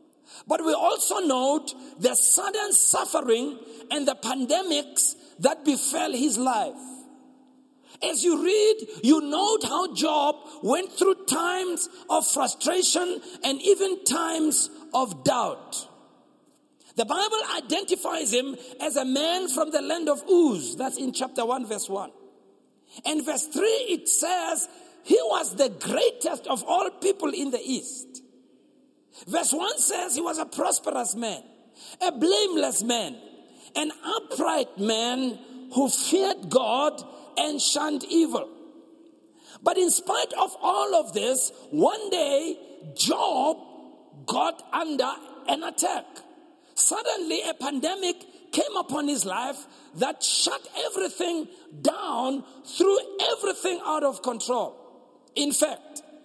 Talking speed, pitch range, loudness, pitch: 125 wpm, 270-355 Hz, -24 LUFS, 310 Hz